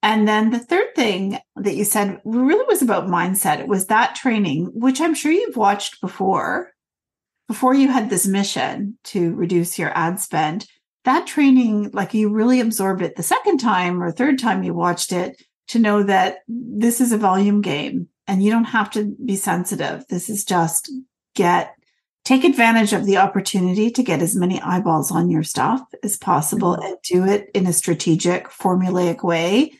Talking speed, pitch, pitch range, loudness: 180 wpm, 205 Hz, 180-235 Hz, -19 LUFS